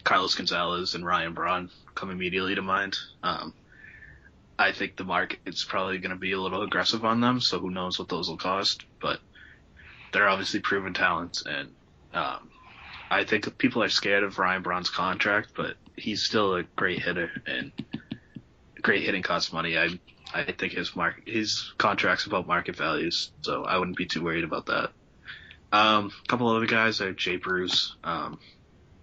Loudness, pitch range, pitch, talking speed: -27 LUFS, 90-105 Hz, 95 Hz, 175 wpm